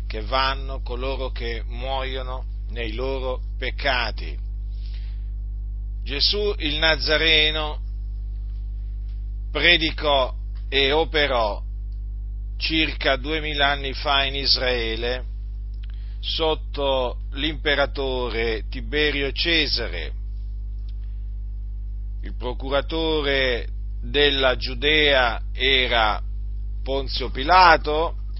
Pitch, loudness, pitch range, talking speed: 120 Hz, -21 LUFS, 100-140 Hz, 65 wpm